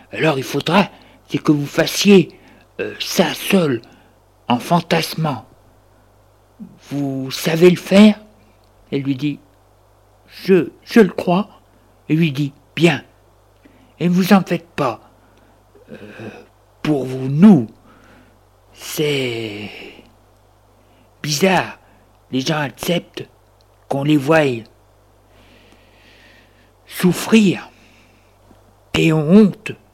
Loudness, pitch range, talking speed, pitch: -17 LUFS, 105-160 Hz, 100 wpm, 120 Hz